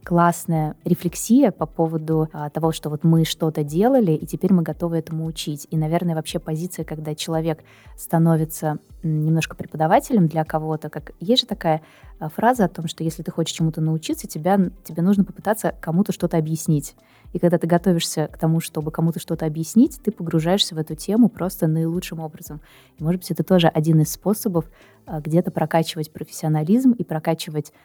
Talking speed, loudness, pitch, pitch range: 170 wpm, -21 LUFS, 165 Hz, 155-180 Hz